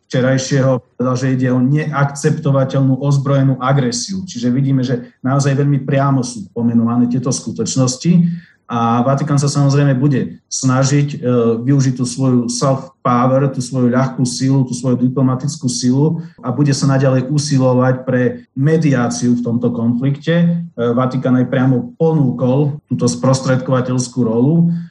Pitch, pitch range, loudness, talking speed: 130 Hz, 125-140 Hz, -15 LUFS, 130 wpm